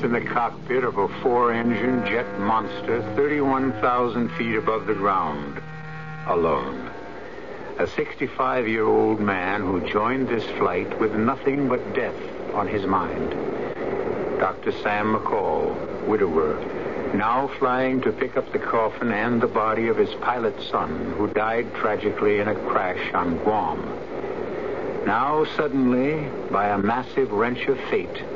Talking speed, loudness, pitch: 140 wpm, -23 LUFS, 155 Hz